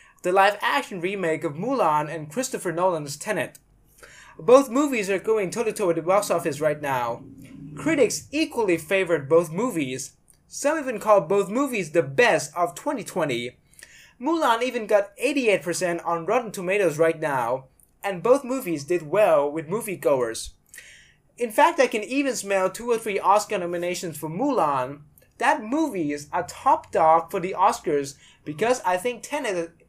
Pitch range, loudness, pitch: 165-240 Hz, -23 LUFS, 195 Hz